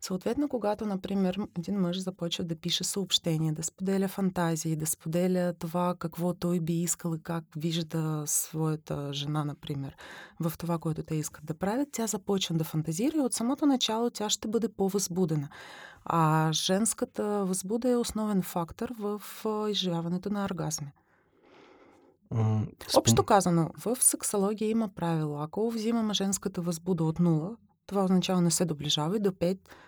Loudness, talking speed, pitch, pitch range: -29 LUFS, 150 wpm, 180 Hz, 165-210 Hz